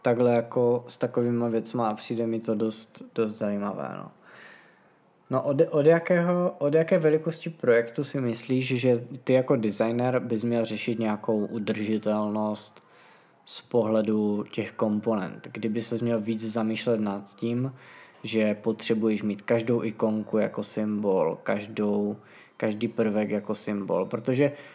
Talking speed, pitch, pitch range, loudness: 135 wpm, 115 Hz, 110-125 Hz, -27 LUFS